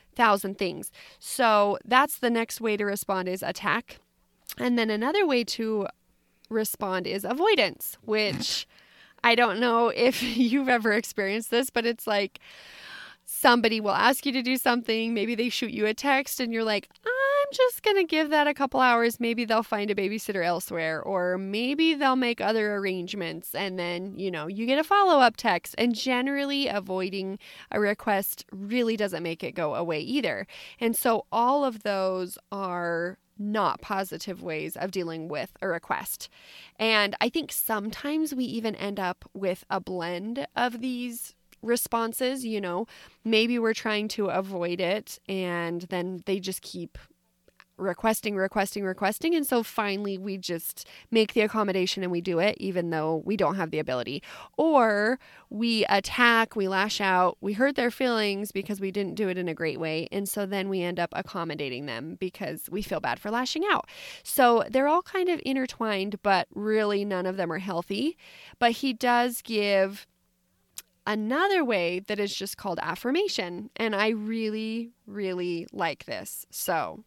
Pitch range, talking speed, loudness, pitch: 190-240 Hz, 170 wpm, -27 LUFS, 210 Hz